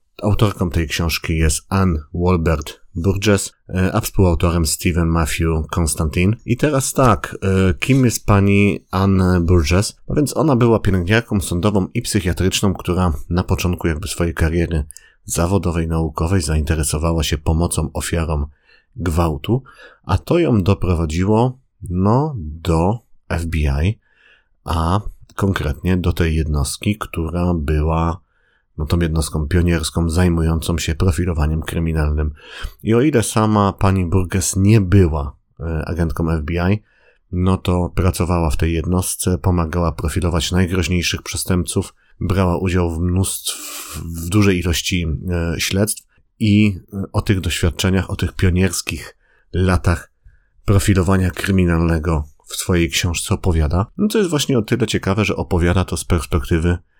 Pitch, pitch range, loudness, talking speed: 90 Hz, 85-100 Hz, -18 LUFS, 125 wpm